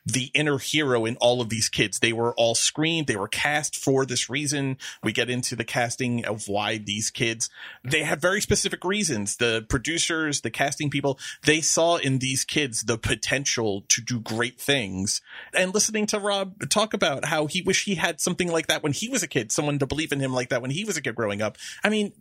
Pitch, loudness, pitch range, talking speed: 140 Hz, -24 LUFS, 120-165 Hz, 225 wpm